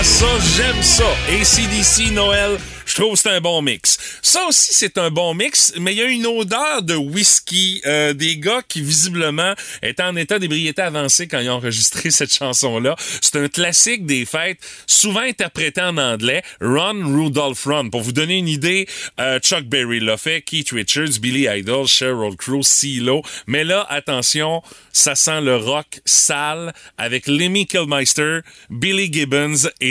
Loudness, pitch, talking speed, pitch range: -15 LUFS, 155 Hz, 175 wpm, 140-180 Hz